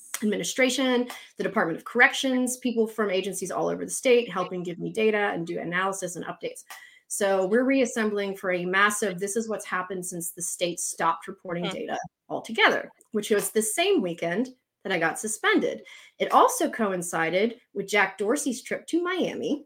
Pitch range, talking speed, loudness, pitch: 185-245 Hz, 170 wpm, -26 LUFS, 210 Hz